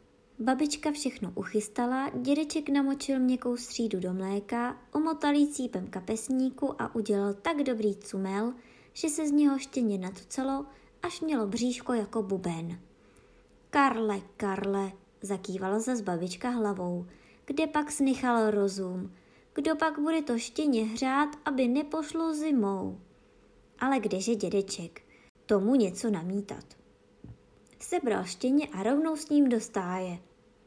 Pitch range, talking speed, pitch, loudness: 200-280 Hz, 120 wpm, 240 Hz, -30 LUFS